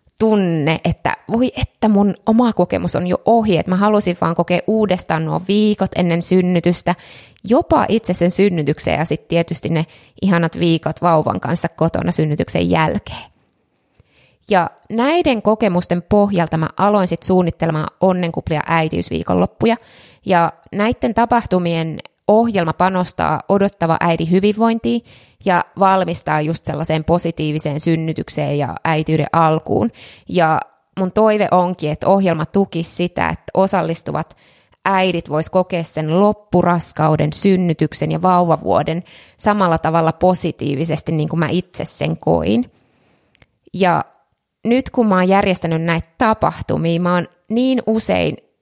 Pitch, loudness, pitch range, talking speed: 175 Hz, -17 LUFS, 160-195 Hz, 125 wpm